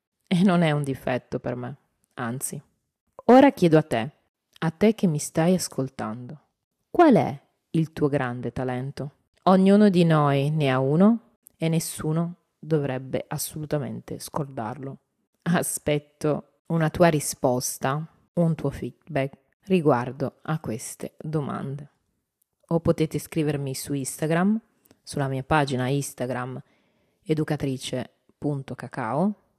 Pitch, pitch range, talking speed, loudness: 150 Hz, 130-170 Hz, 115 wpm, -24 LUFS